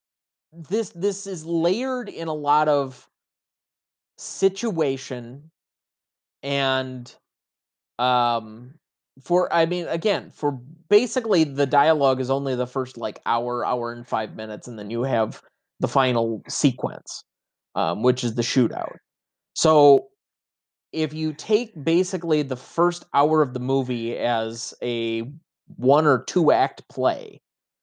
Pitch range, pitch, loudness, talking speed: 125-165 Hz, 140 Hz, -23 LUFS, 125 wpm